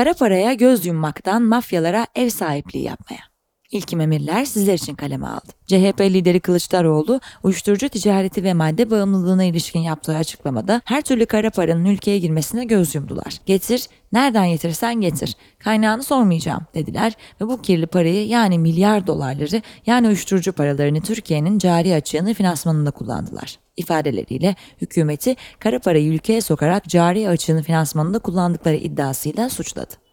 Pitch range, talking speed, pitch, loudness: 160-220 Hz, 135 wpm, 185 Hz, -19 LUFS